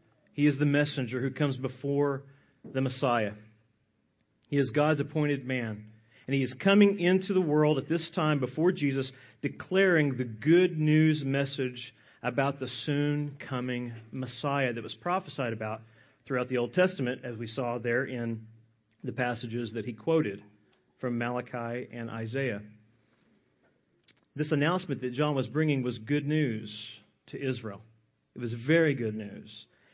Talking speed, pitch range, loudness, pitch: 150 wpm, 115-145 Hz, -30 LUFS, 130 Hz